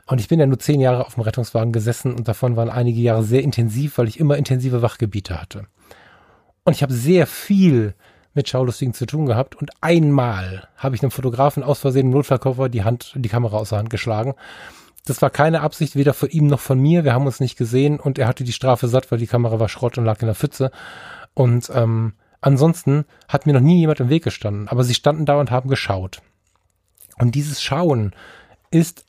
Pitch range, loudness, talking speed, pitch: 115-145 Hz, -19 LUFS, 215 wpm, 130 Hz